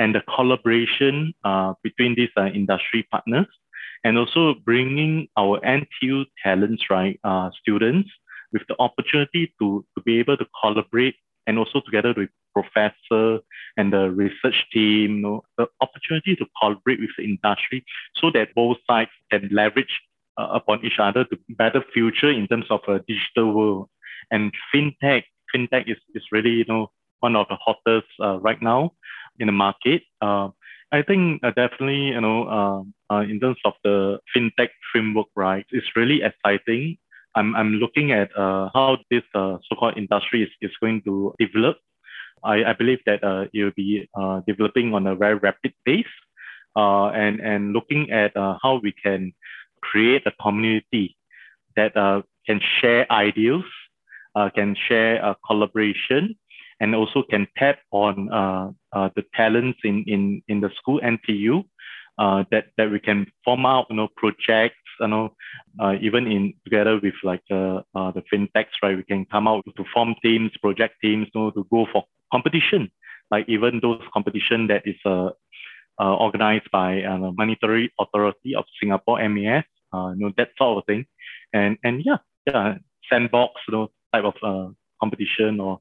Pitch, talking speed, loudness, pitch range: 110 Hz, 170 wpm, -21 LUFS, 100-120 Hz